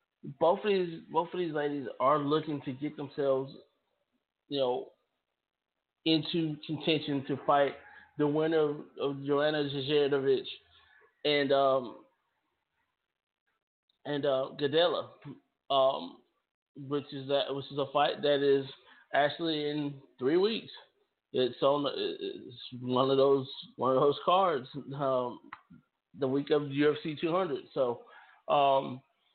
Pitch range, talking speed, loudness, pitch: 140-160 Hz, 125 wpm, -30 LUFS, 145 Hz